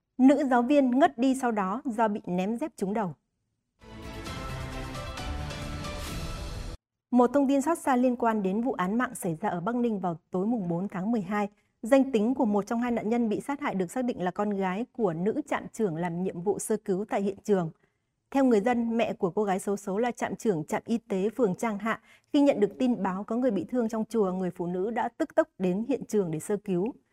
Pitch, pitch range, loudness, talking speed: 215 Hz, 185-245 Hz, -28 LUFS, 235 wpm